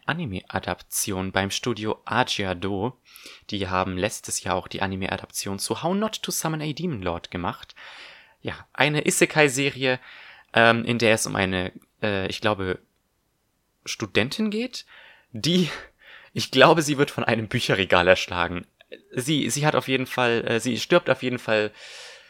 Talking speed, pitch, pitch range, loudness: 150 wpm, 115 Hz, 100-145 Hz, -24 LUFS